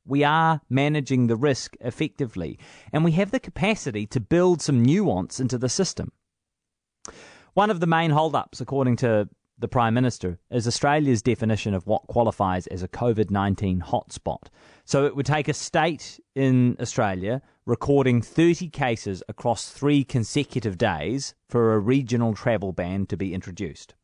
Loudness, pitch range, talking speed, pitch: -24 LUFS, 110-145 Hz, 150 wpm, 125 Hz